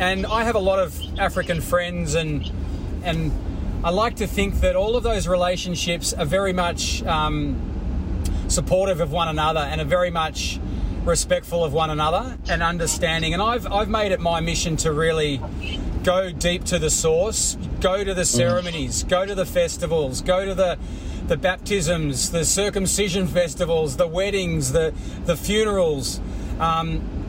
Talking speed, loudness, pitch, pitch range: 160 wpm, -22 LUFS, 170 Hz, 150-185 Hz